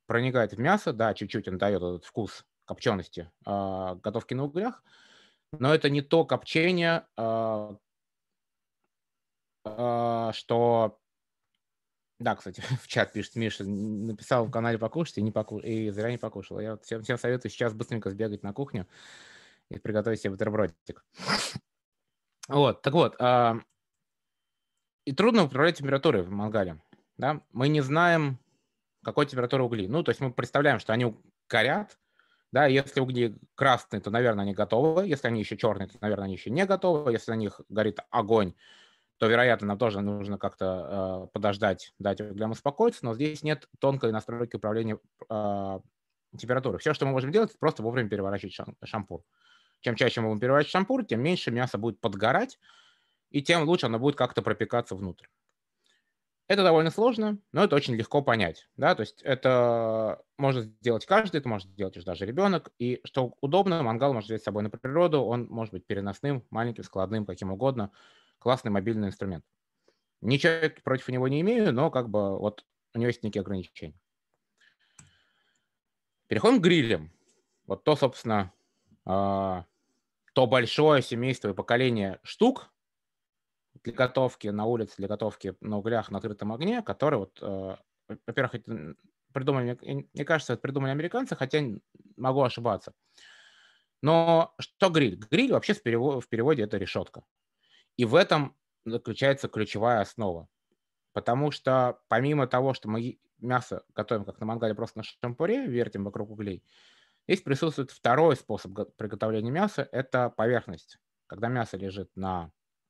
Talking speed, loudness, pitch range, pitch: 150 wpm, -28 LUFS, 105-135 Hz, 115 Hz